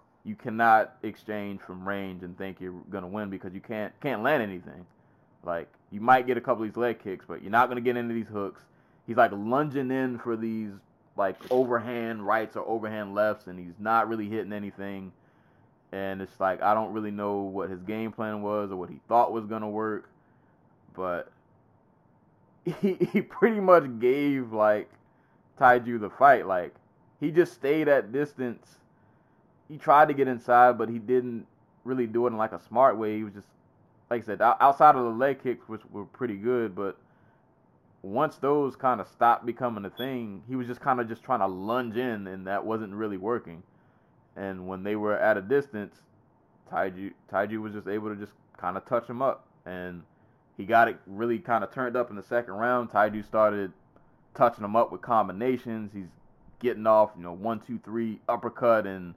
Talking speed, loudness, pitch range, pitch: 195 wpm, -27 LUFS, 100-125 Hz, 110 Hz